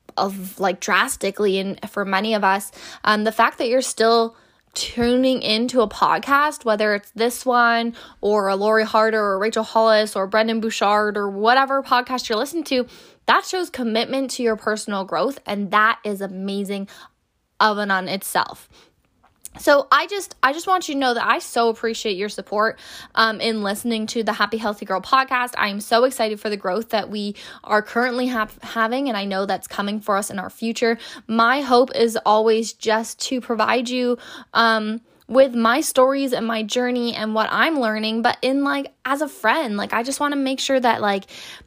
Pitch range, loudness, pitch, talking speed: 210-250 Hz, -20 LUFS, 225 Hz, 195 wpm